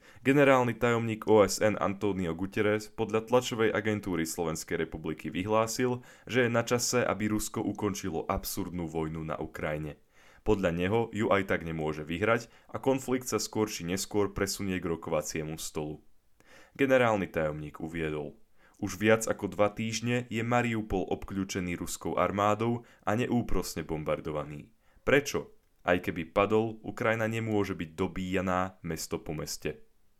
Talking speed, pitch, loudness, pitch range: 130 wpm, 100 Hz, -30 LUFS, 85-110 Hz